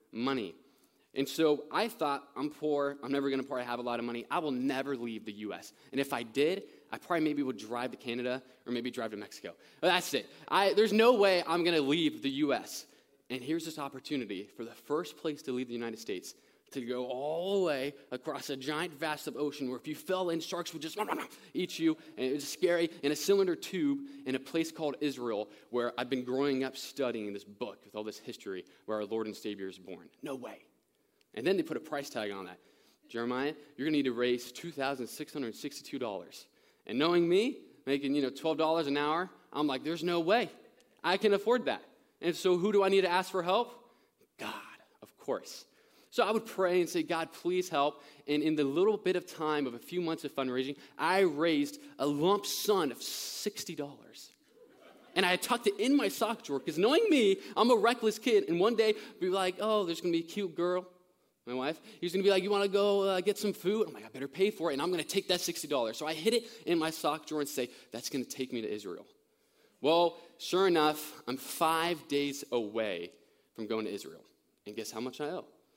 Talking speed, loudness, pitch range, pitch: 235 wpm, -33 LUFS, 130-185 Hz, 155 Hz